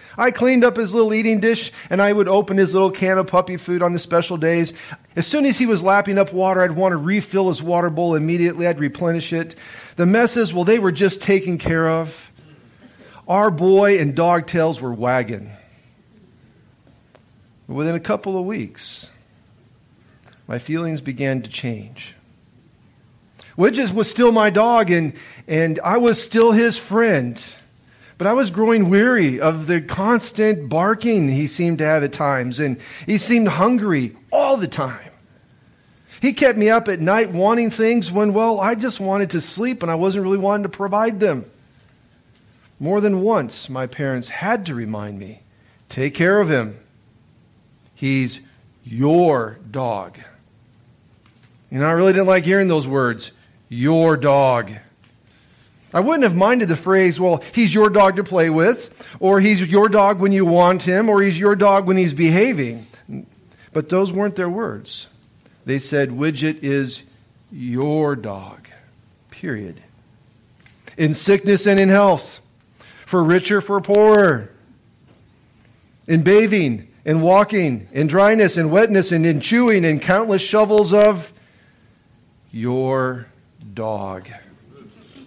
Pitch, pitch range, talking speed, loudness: 175 Hz, 135-205 Hz, 150 wpm, -17 LUFS